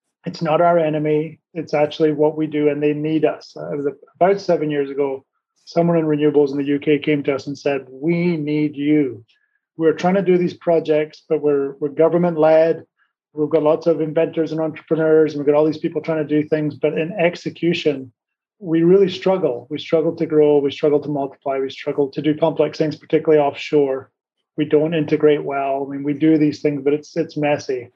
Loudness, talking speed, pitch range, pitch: -19 LUFS, 210 wpm, 145-160 Hz, 150 Hz